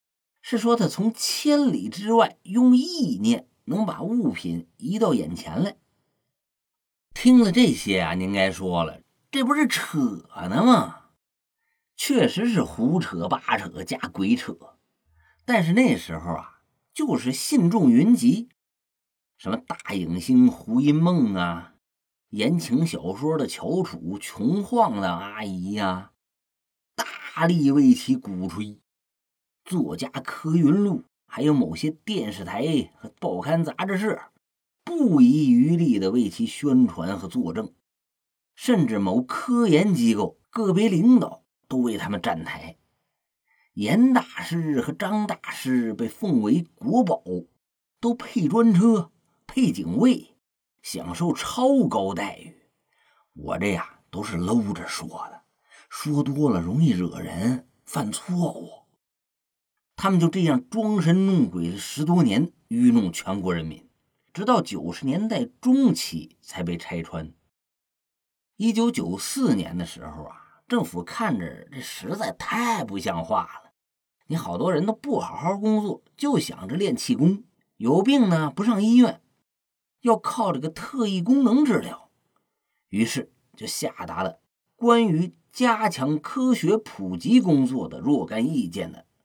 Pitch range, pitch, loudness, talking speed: 145-245 Hz, 215 Hz, -23 LUFS, 190 characters per minute